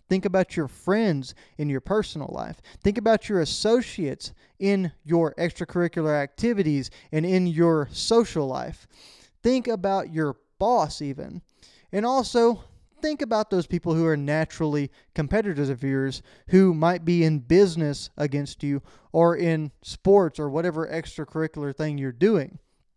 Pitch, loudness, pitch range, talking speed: 165 Hz, -24 LUFS, 145-195 Hz, 140 wpm